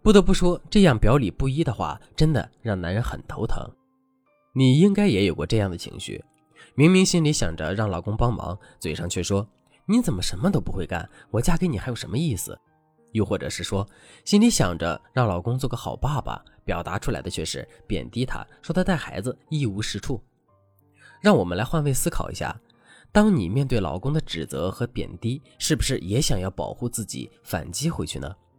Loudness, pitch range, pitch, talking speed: -24 LUFS, 95-155 Hz, 125 Hz, 290 characters per minute